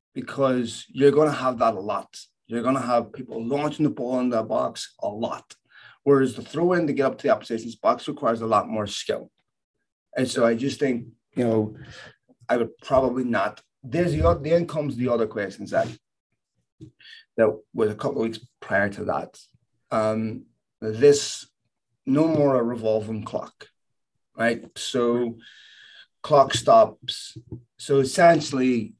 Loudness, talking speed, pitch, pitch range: -24 LUFS, 155 wpm, 120 Hz, 115-140 Hz